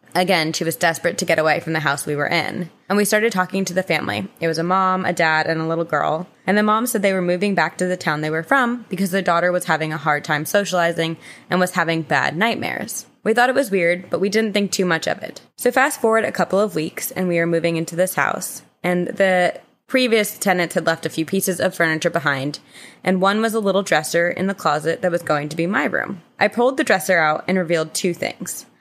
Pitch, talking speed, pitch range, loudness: 180 Hz, 255 wpm, 165-195 Hz, -19 LUFS